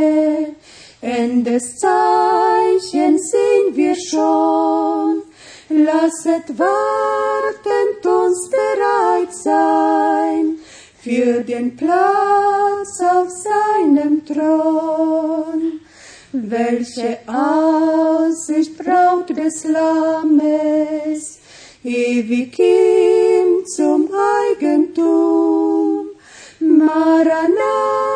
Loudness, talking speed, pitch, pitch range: -16 LUFS, 55 wpm, 315 Hz, 245-360 Hz